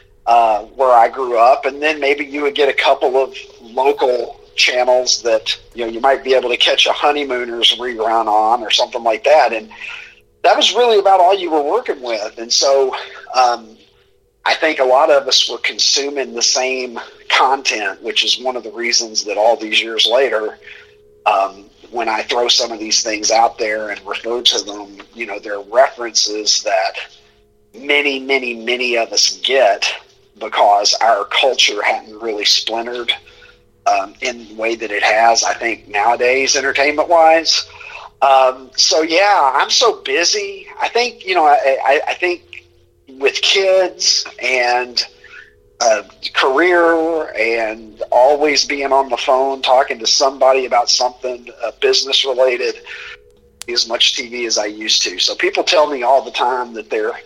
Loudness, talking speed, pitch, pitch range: -14 LUFS, 170 wpm, 130 Hz, 115-165 Hz